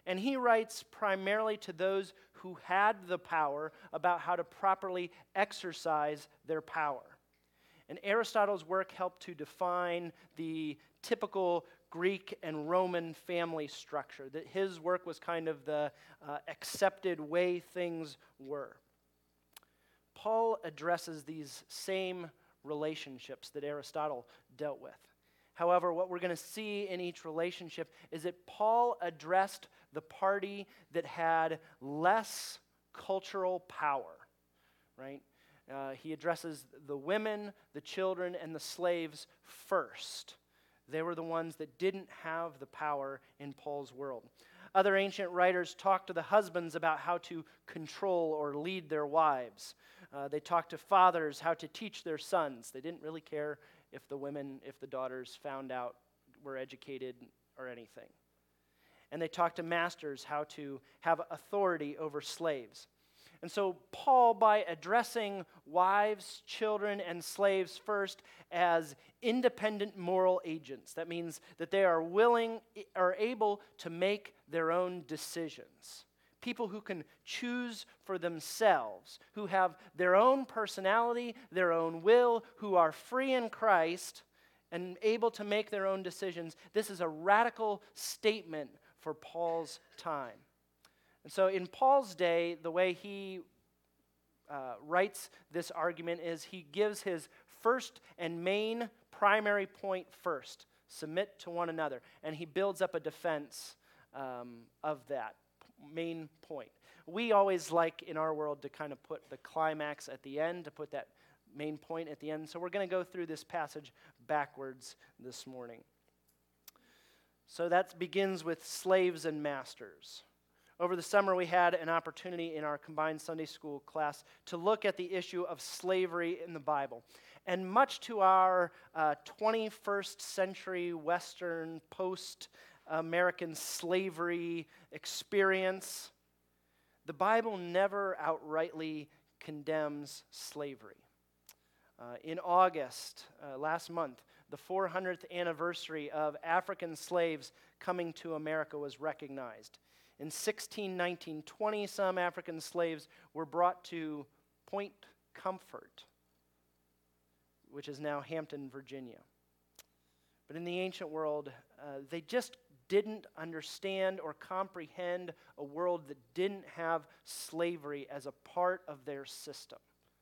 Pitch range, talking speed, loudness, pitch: 150-190 Hz, 135 wpm, -36 LUFS, 170 Hz